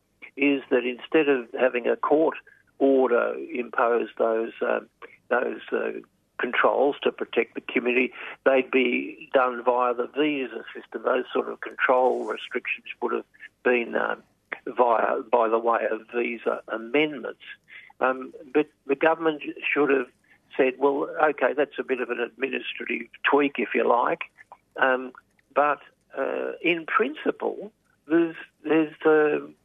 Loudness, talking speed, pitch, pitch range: -25 LUFS, 140 wpm, 135 Hz, 125-150 Hz